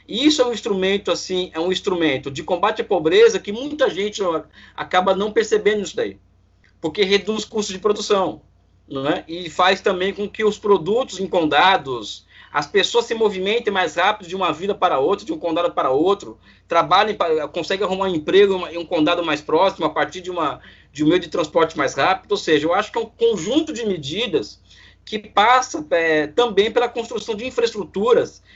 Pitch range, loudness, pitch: 170-230 Hz, -19 LUFS, 195 Hz